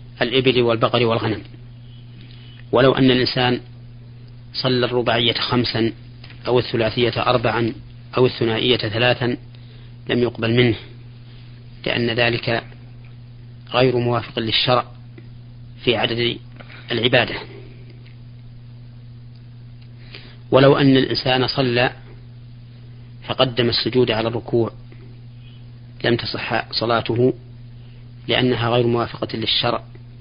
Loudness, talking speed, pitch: -19 LUFS, 80 wpm, 120 Hz